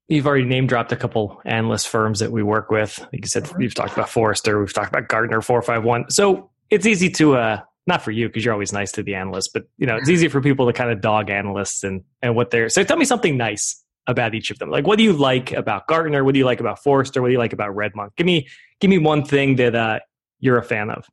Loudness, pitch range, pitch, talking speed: -19 LUFS, 110-135 Hz, 120 Hz, 275 wpm